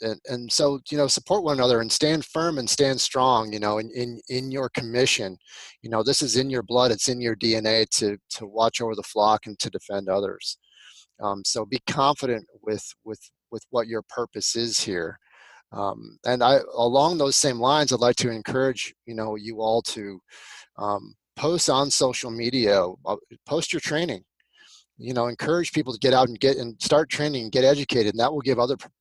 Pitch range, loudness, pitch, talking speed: 110-140 Hz, -23 LUFS, 125 Hz, 205 wpm